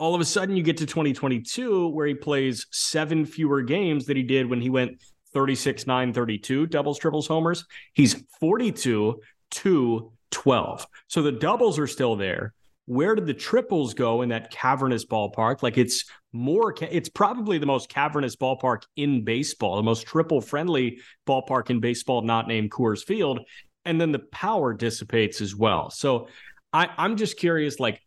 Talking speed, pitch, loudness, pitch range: 170 wpm, 135 Hz, -25 LUFS, 120-160 Hz